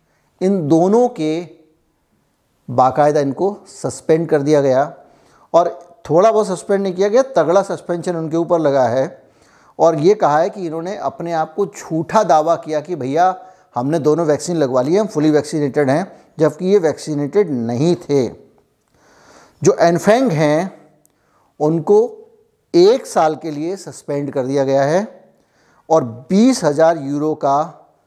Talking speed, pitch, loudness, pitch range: 145 wpm, 165 Hz, -16 LUFS, 150-190 Hz